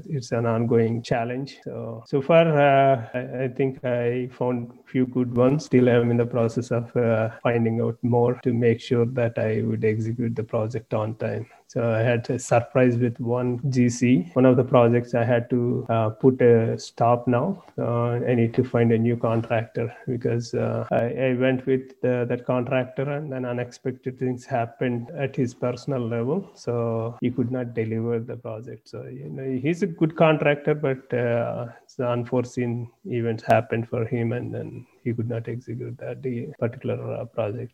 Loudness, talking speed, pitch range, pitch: -24 LUFS, 185 wpm, 115-130 Hz, 120 Hz